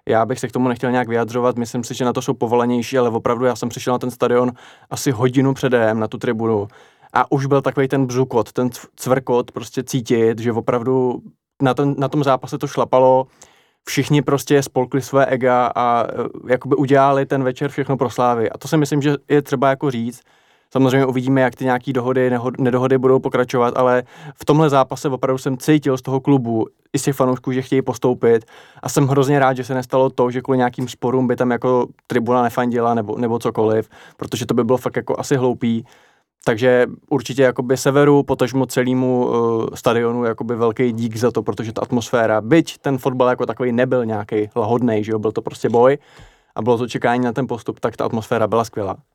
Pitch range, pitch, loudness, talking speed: 120-135 Hz, 125 Hz, -18 LUFS, 205 wpm